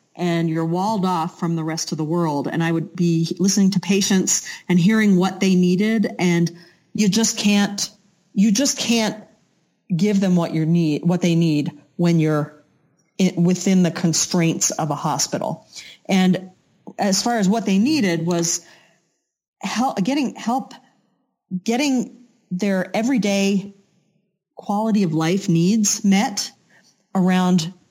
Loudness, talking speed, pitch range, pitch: -19 LUFS, 140 wpm, 170-205 Hz, 185 Hz